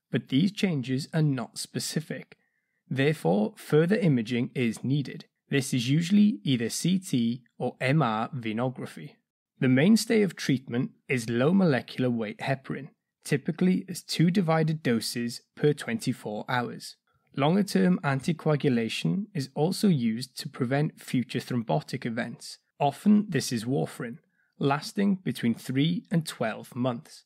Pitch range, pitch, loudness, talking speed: 125-180 Hz, 145 Hz, -27 LUFS, 125 wpm